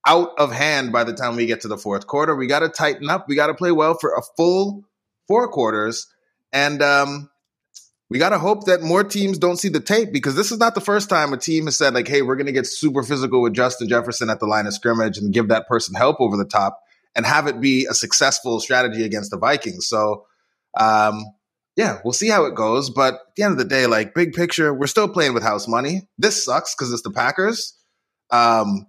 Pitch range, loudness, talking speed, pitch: 115-175 Hz, -19 LUFS, 240 wpm, 140 Hz